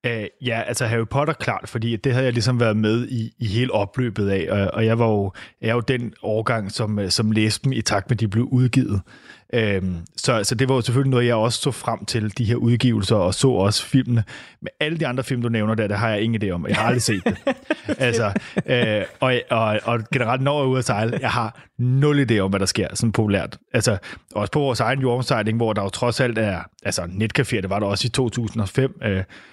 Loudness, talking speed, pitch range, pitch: -21 LUFS, 245 wpm, 105-125 Hz, 115 Hz